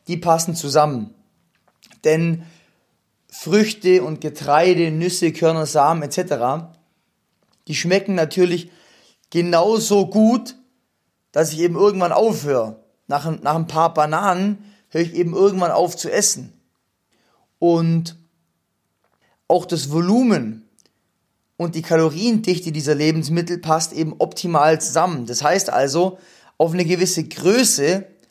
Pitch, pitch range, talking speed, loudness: 170 Hz, 155-185 Hz, 115 wpm, -18 LUFS